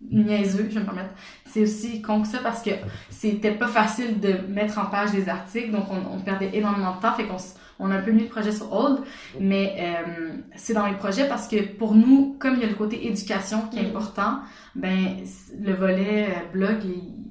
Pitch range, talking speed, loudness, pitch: 195-220 Hz, 220 wpm, -24 LUFS, 210 Hz